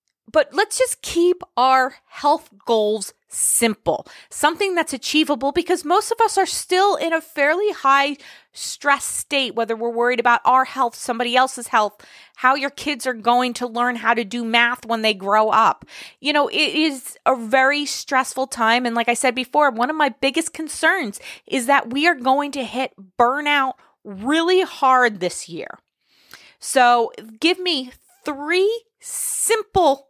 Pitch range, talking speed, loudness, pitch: 240-320 Hz, 165 wpm, -19 LUFS, 270 Hz